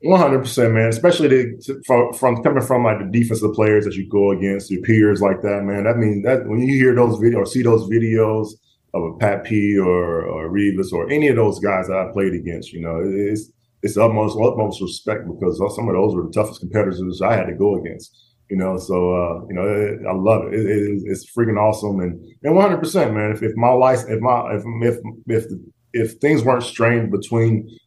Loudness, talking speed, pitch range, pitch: -18 LUFS, 235 wpm, 100-120 Hz, 110 Hz